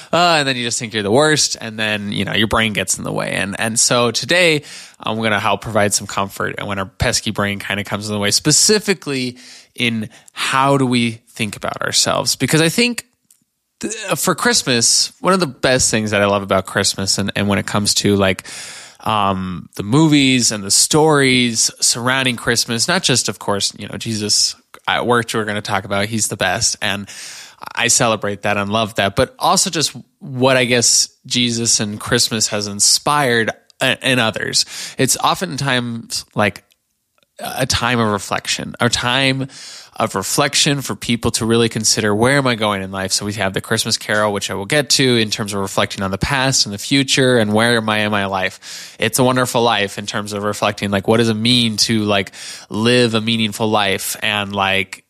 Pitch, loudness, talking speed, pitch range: 115 Hz, -16 LUFS, 205 wpm, 105-125 Hz